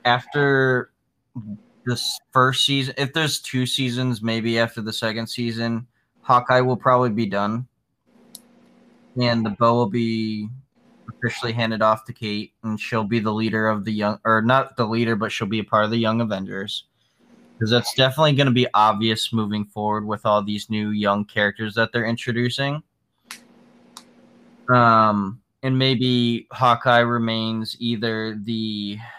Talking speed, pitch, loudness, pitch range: 150 wpm, 115 Hz, -21 LUFS, 110-125 Hz